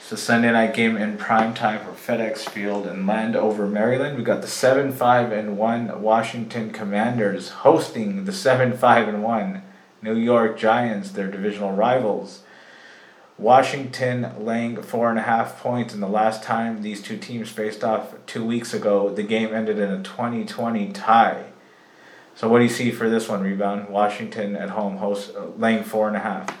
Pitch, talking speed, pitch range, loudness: 110 Hz, 185 wpm, 105-120 Hz, -22 LUFS